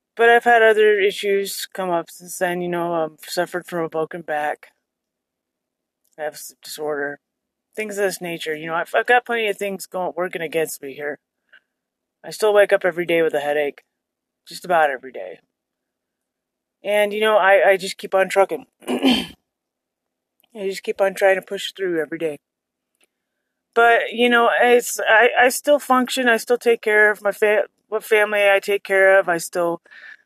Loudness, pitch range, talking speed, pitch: -19 LUFS, 170-215 Hz, 185 wpm, 195 Hz